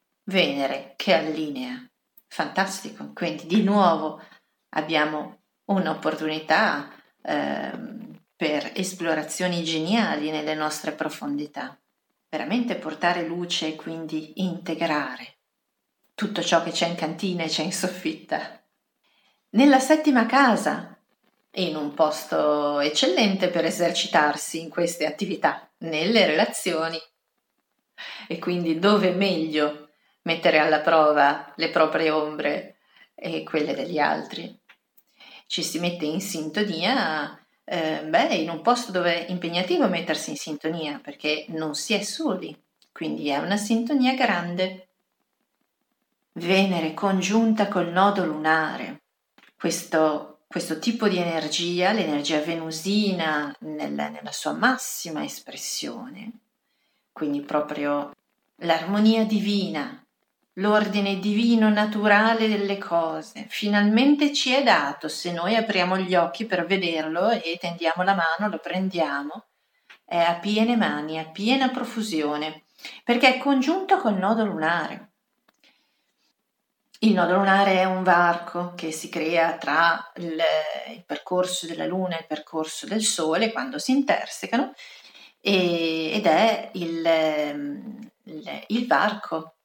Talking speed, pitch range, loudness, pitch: 115 wpm, 160-215 Hz, -24 LUFS, 175 Hz